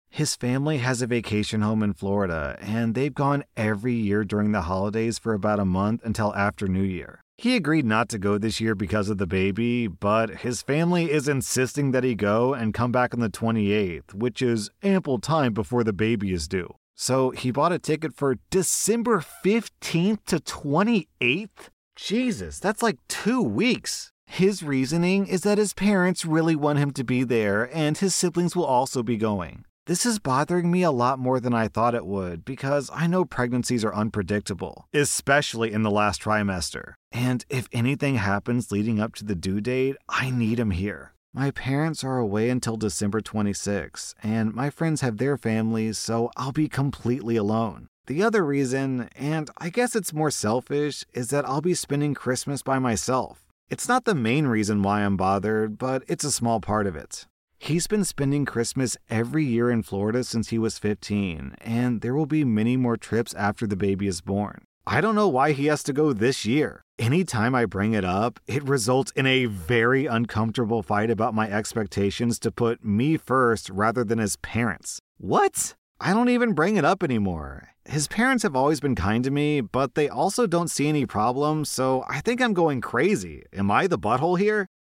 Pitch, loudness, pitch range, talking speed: 125 Hz, -24 LUFS, 110-145 Hz, 190 wpm